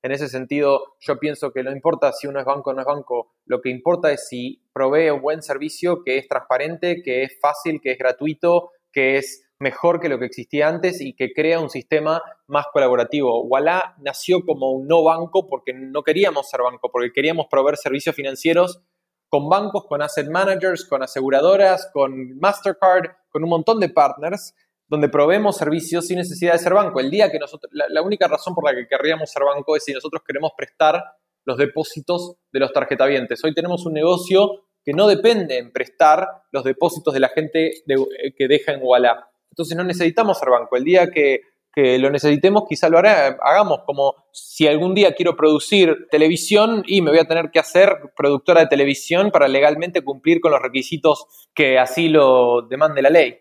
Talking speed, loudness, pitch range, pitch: 195 wpm, -18 LUFS, 140-175 Hz, 155 Hz